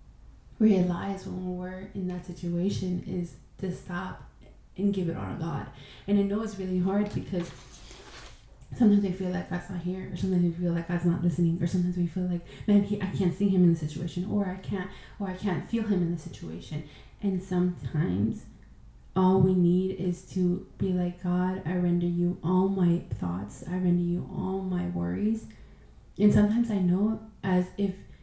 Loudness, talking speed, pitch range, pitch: -28 LUFS, 190 wpm, 175-190 Hz, 180 Hz